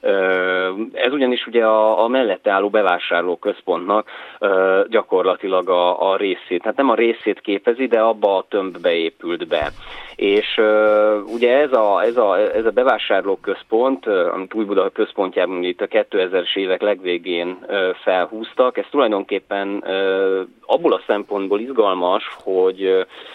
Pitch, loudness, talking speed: 110 Hz, -18 LUFS, 145 wpm